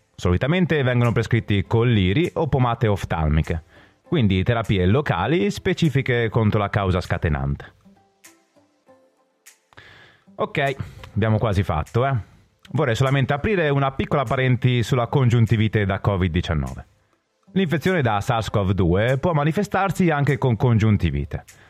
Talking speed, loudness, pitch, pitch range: 105 wpm, -21 LUFS, 115 Hz, 100-140 Hz